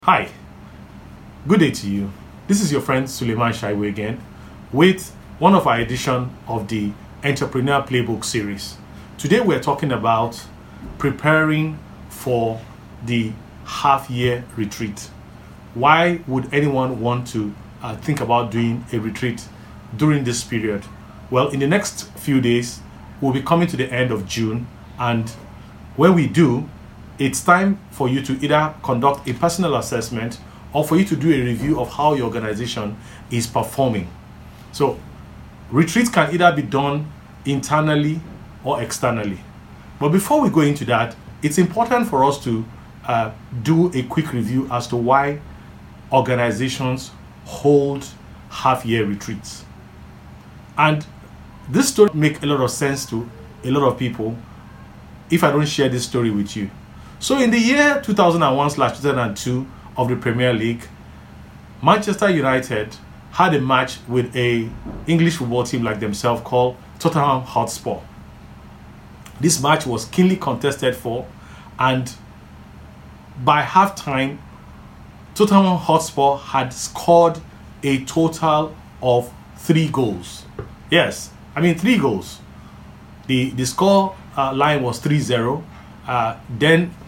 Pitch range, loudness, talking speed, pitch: 110-150 Hz, -19 LUFS, 135 wpm, 125 Hz